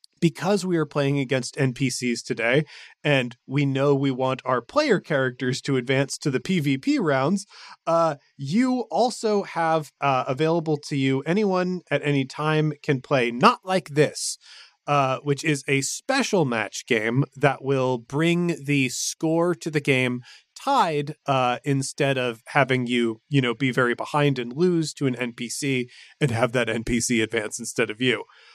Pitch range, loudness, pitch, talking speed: 130-160 Hz, -23 LUFS, 140 Hz, 160 wpm